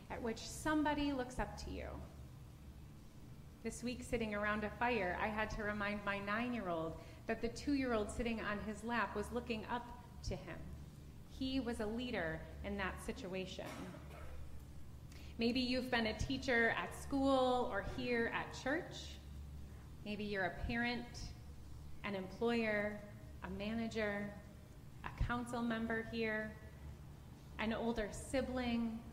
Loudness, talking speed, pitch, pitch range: -41 LUFS, 140 wpm, 220 Hz, 190-240 Hz